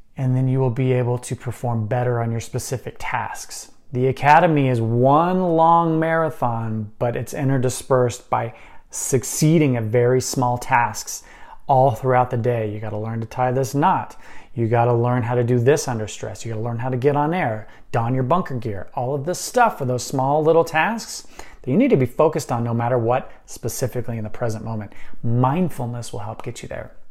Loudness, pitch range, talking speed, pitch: -20 LUFS, 120-145 Hz, 200 wpm, 125 Hz